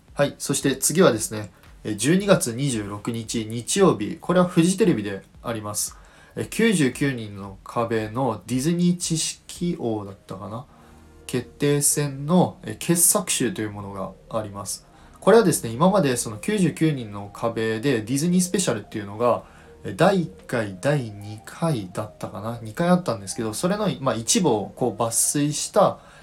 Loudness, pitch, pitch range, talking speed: -23 LUFS, 120 Hz, 105-160 Hz, 280 characters per minute